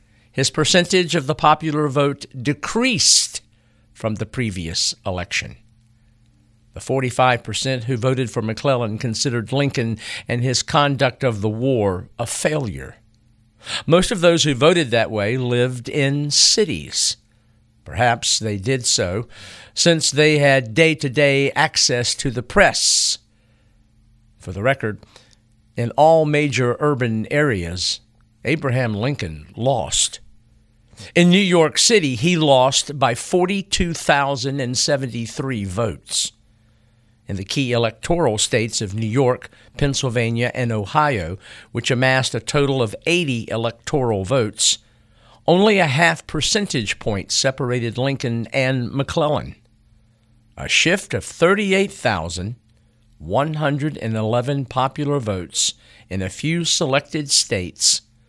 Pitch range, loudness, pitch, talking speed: 115-140 Hz, -18 LUFS, 120 Hz, 115 wpm